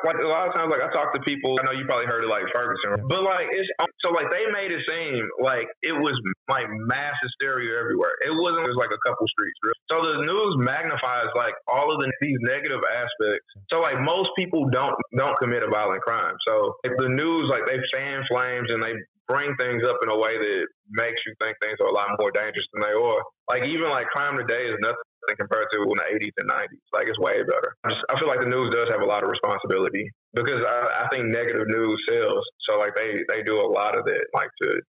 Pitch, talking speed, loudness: 380 Hz, 240 wpm, -24 LUFS